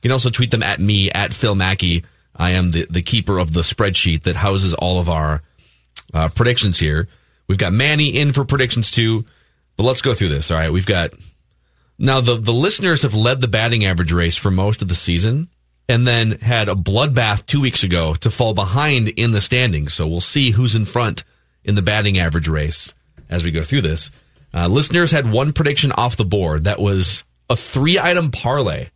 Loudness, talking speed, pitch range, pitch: -17 LUFS, 205 wpm, 85-125 Hz, 100 Hz